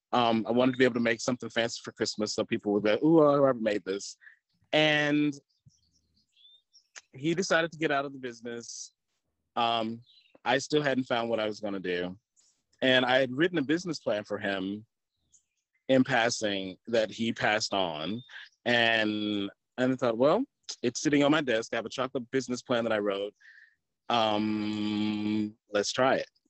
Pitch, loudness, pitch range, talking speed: 115 Hz, -28 LUFS, 105-130 Hz, 180 wpm